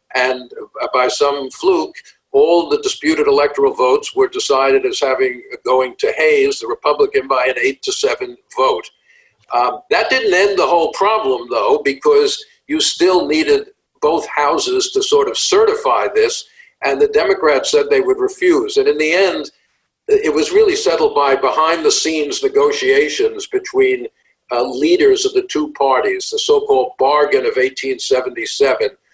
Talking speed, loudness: 155 wpm, -15 LUFS